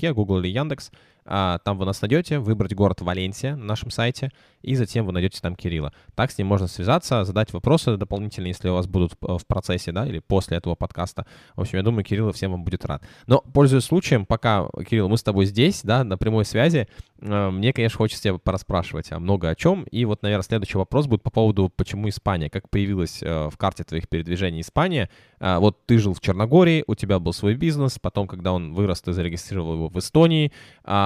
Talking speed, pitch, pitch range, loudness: 205 wpm, 100 Hz, 90-120 Hz, -23 LUFS